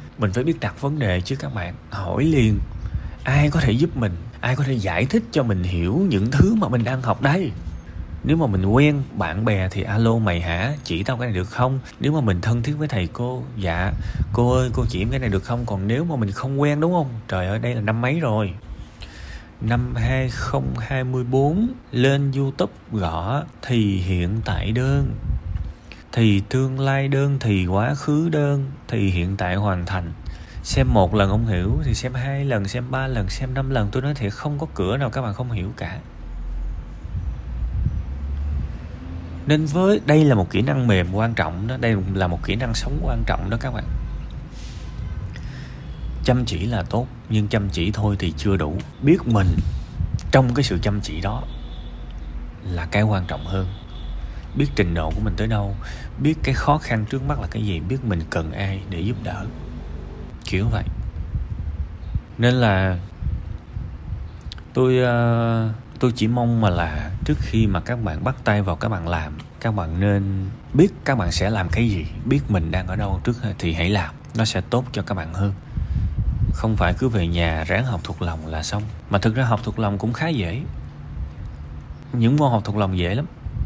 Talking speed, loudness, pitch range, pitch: 195 wpm, -22 LUFS, 90-125 Hz, 105 Hz